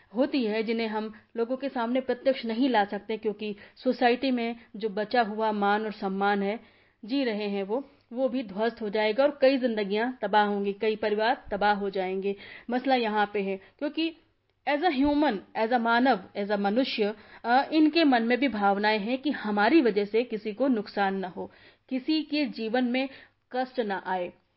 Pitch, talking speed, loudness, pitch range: 225 Hz, 185 wpm, -27 LUFS, 210-260 Hz